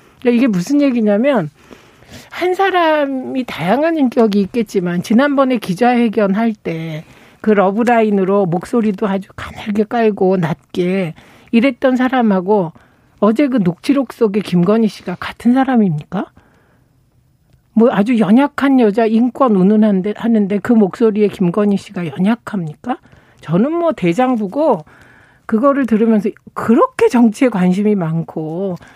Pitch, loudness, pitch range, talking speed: 215 Hz, -15 LUFS, 185-245 Hz, 285 characters per minute